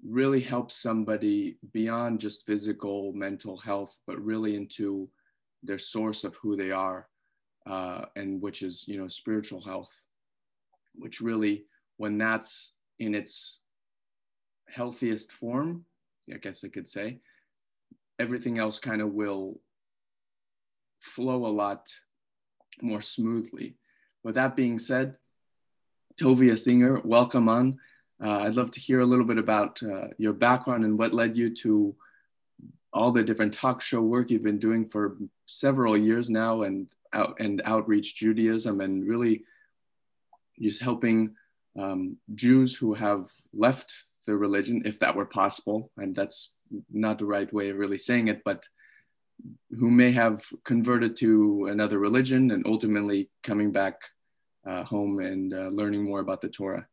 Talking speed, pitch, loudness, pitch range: 145 wpm, 110 Hz, -27 LUFS, 100-120 Hz